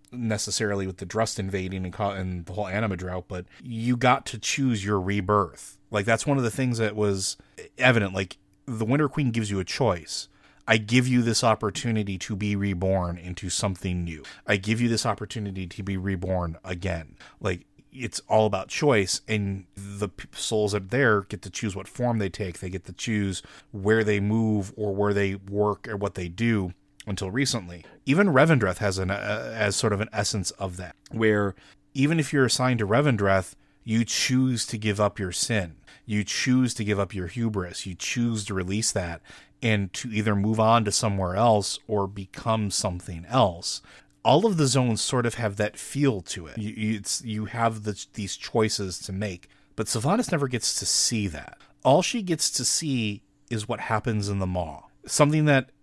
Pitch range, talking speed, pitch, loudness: 95-115 Hz, 195 wpm, 105 Hz, -26 LUFS